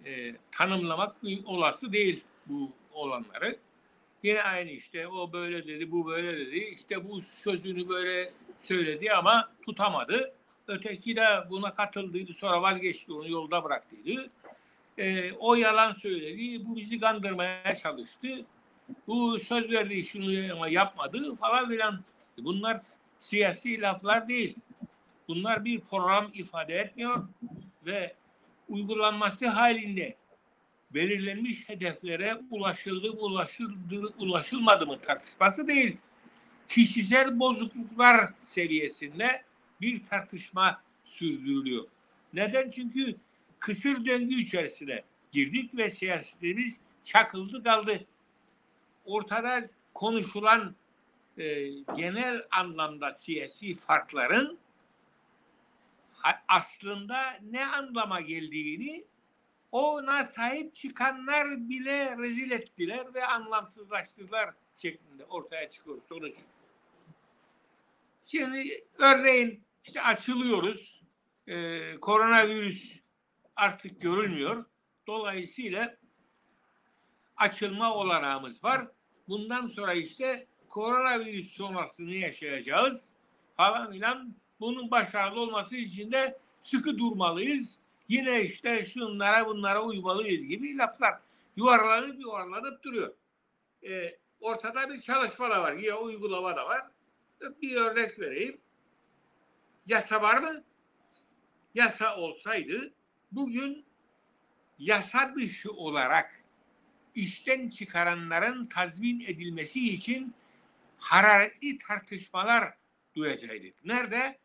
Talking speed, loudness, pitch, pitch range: 90 wpm, -29 LUFS, 220 Hz, 190-250 Hz